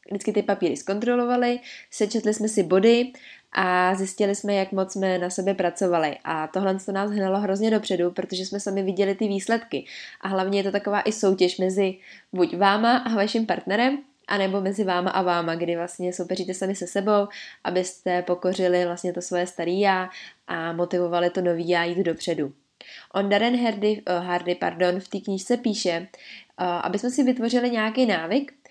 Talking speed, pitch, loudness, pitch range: 180 wpm, 195 Hz, -24 LUFS, 180-210 Hz